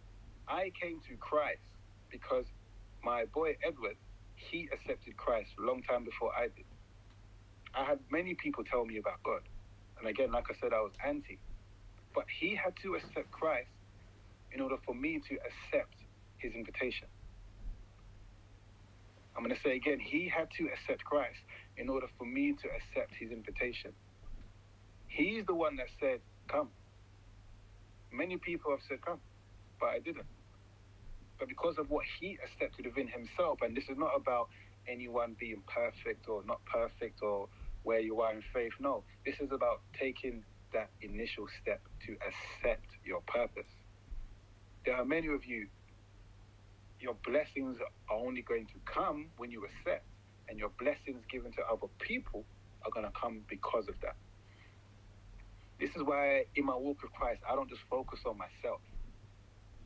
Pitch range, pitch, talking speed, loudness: 100-125 Hz, 105 Hz, 160 wpm, -38 LUFS